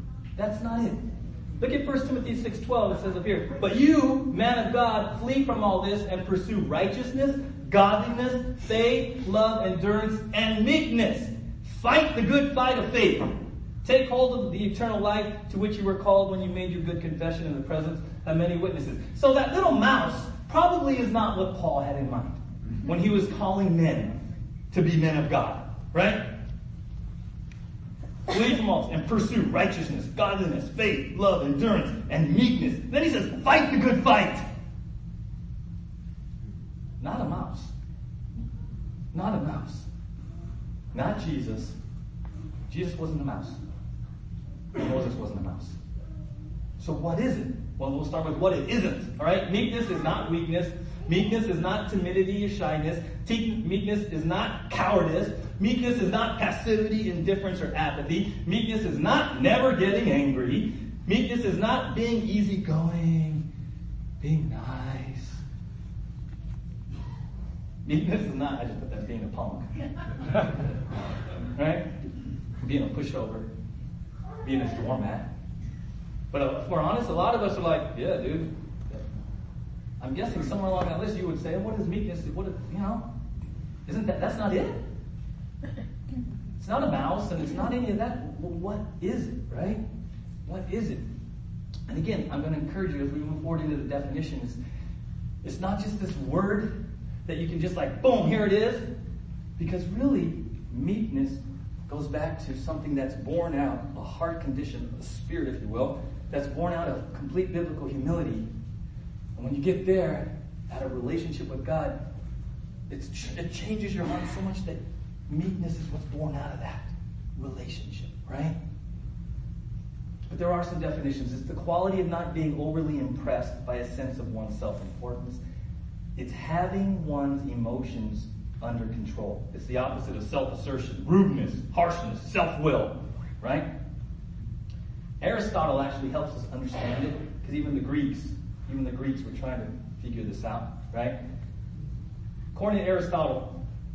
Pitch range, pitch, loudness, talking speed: 135-205 Hz, 165 Hz, -28 LUFS, 155 wpm